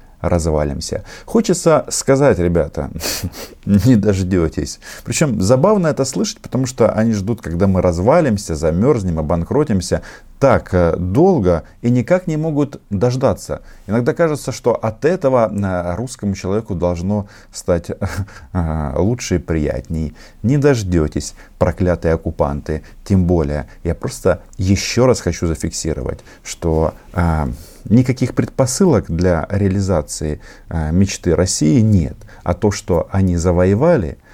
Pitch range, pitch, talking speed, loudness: 85-120 Hz, 95 Hz, 110 wpm, -17 LUFS